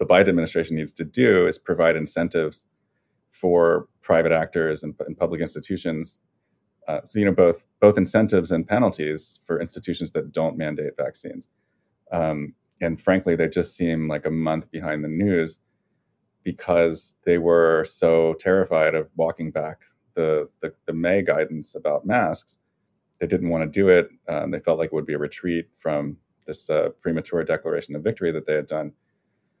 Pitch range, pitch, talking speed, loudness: 75-85 Hz, 80 Hz, 170 wpm, -23 LUFS